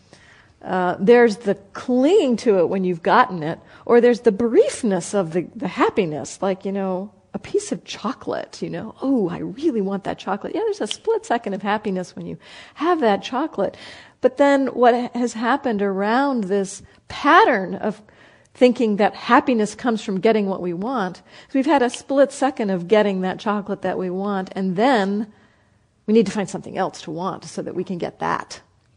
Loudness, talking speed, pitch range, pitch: -20 LUFS, 190 wpm, 190-250 Hz, 210 Hz